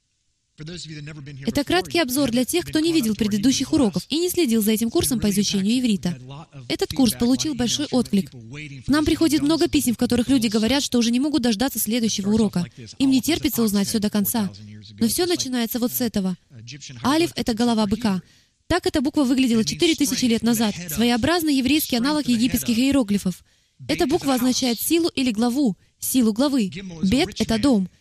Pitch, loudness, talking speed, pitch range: 240 Hz, -21 LUFS, 170 wpm, 205-285 Hz